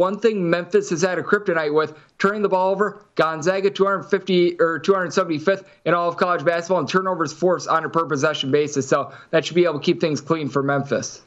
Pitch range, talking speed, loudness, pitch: 155-190 Hz, 215 wpm, -21 LUFS, 175 Hz